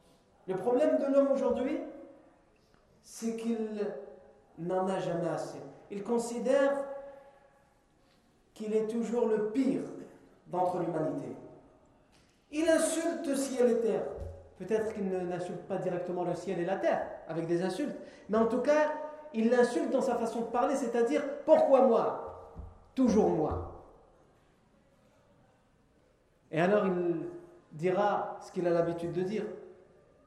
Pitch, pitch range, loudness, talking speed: 220 Hz, 185-270 Hz, -31 LUFS, 130 wpm